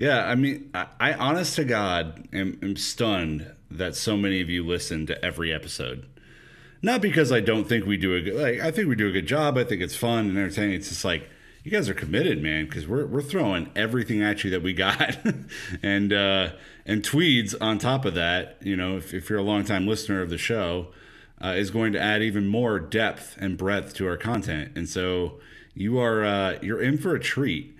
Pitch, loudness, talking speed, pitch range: 100 Hz, -25 LUFS, 220 wpm, 95-115 Hz